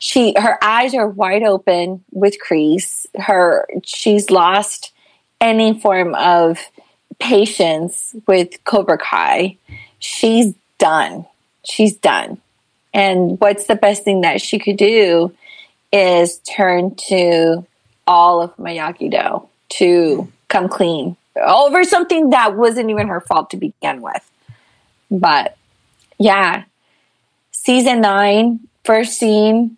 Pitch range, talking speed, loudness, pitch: 180-225 Hz, 115 wpm, -14 LUFS, 205 Hz